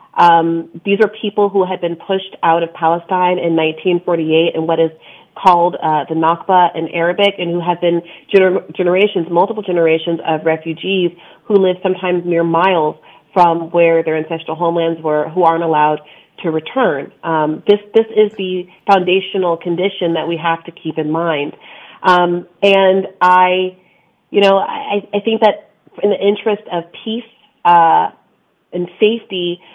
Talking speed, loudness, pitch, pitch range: 160 wpm, -15 LUFS, 175 Hz, 165-195 Hz